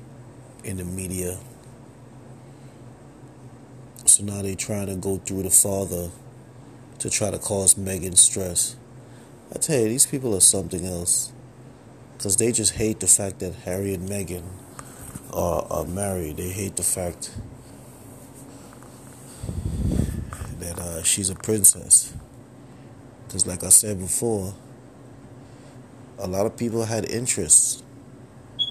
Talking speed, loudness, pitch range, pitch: 125 wpm, -21 LUFS, 95-125 Hz, 115 Hz